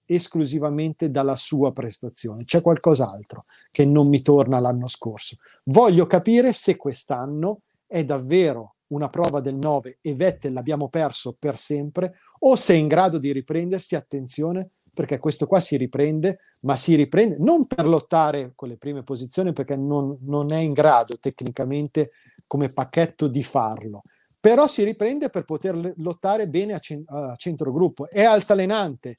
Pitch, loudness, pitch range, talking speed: 150 Hz, -21 LUFS, 140-180 Hz, 155 wpm